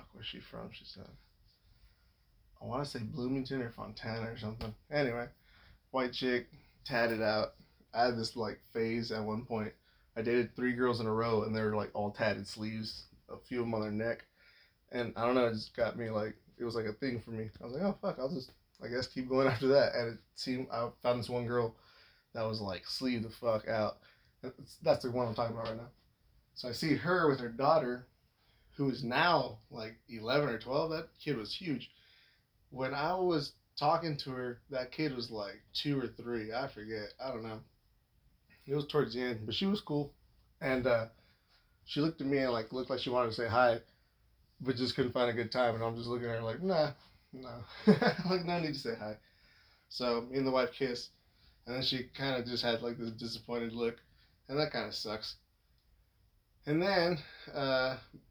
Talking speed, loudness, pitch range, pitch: 215 wpm, -35 LUFS, 110-130 Hz, 120 Hz